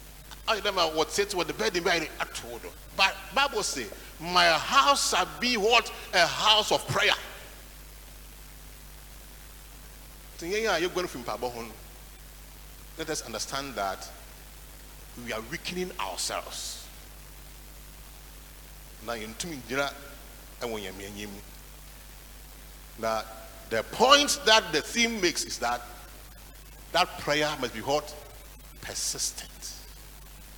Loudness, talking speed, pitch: -27 LUFS, 85 wpm, 155 Hz